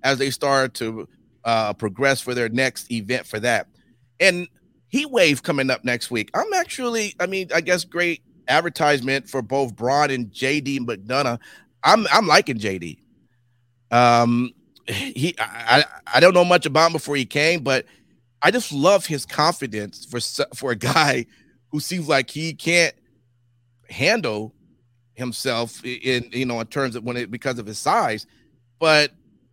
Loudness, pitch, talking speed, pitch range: -20 LUFS, 130 Hz, 165 wpm, 120-150 Hz